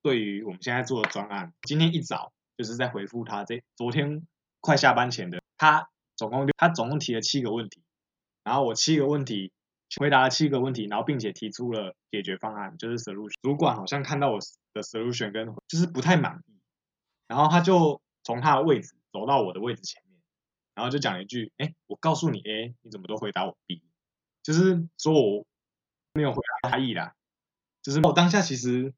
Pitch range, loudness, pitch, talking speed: 110-155 Hz, -26 LUFS, 130 Hz, 320 characters per minute